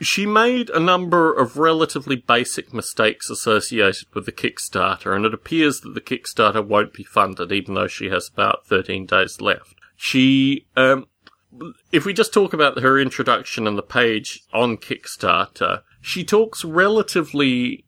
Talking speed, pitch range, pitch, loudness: 155 wpm, 120-180 Hz, 140 Hz, -19 LUFS